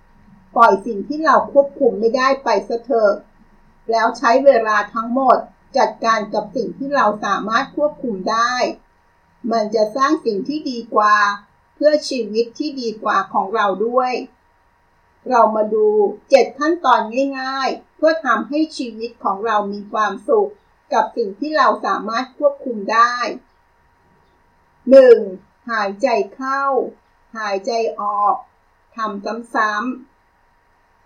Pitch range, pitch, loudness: 215-275 Hz, 235 Hz, -17 LUFS